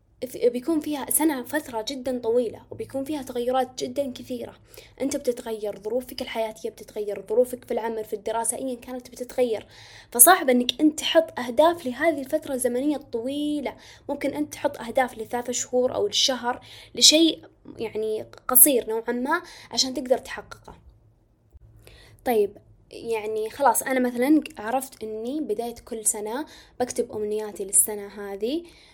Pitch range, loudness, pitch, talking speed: 225-285 Hz, -24 LUFS, 250 Hz, 130 wpm